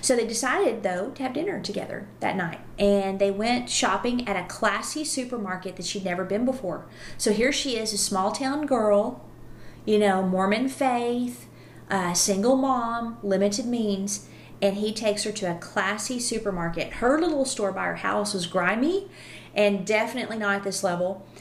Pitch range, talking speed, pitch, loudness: 195-245 Hz, 175 wpm, 210 Hz, -25 LUFS